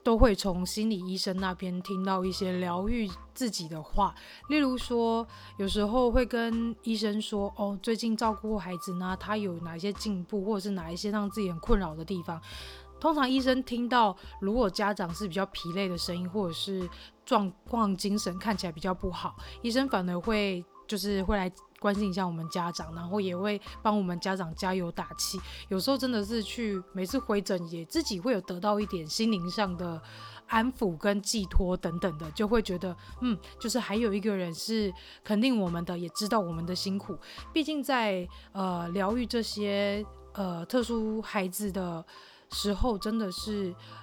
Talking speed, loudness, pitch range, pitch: 270 characters per minute, -31 LUFS, 185-220 Hz, 200 Hz